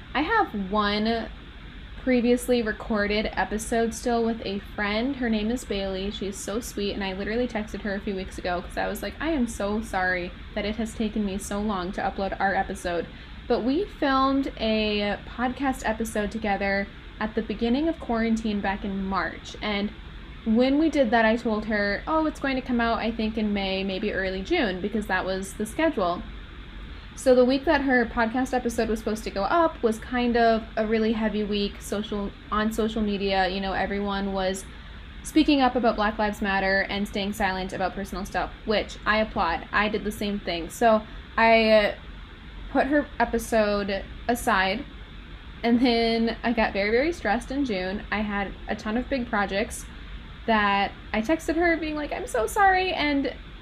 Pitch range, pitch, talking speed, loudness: 200-240 Hz, 215 Hz, 185 wpm, -25 LUFS